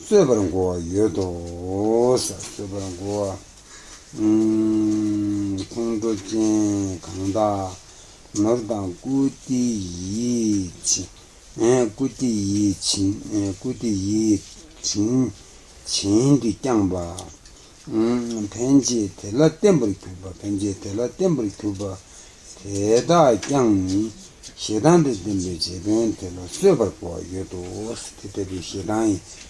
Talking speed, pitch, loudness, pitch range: 80 wpm, 100 Hz, -22 LUFS, 95-110 Hz